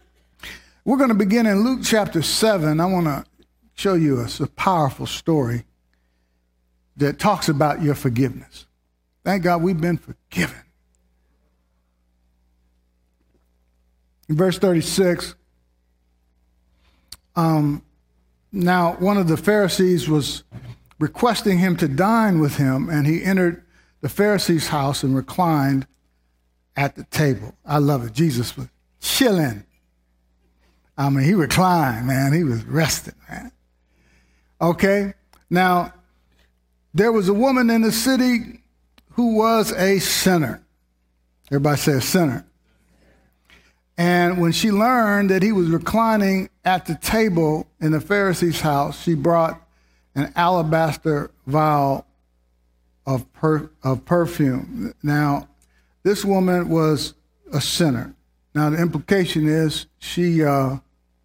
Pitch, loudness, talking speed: 145 Hz, -20 LUFS, 120 wpm